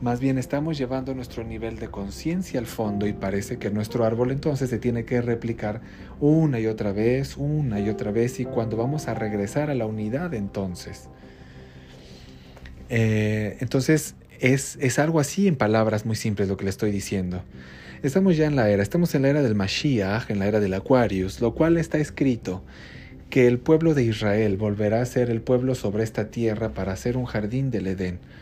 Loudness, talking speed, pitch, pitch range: -24 LUFS, 190 wpm, 115 Hz, 100-130 Hz